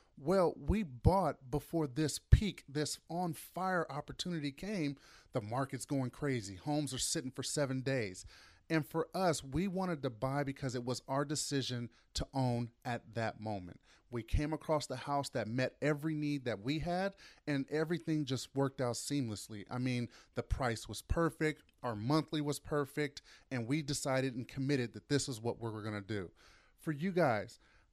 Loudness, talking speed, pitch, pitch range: -37 LUFS, 180 wpm, 135 Hz, 120-150 Hz